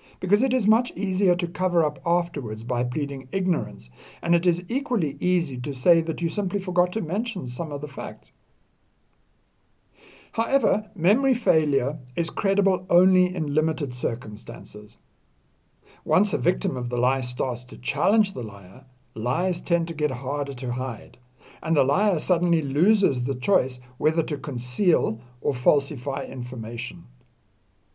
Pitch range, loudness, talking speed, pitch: 125-185 Hz, -24 LUFS, 150 wpm, 155 Hz